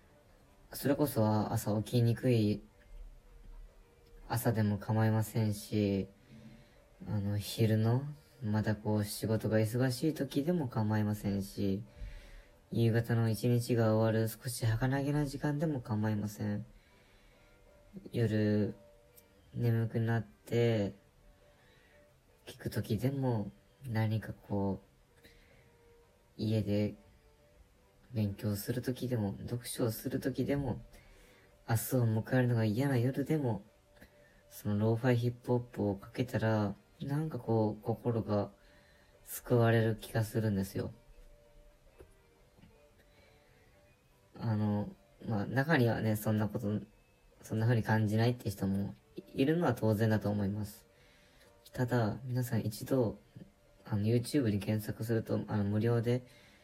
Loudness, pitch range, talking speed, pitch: -34 LUFS, 100-120 Hz, 225 characters per minute, 110 Hz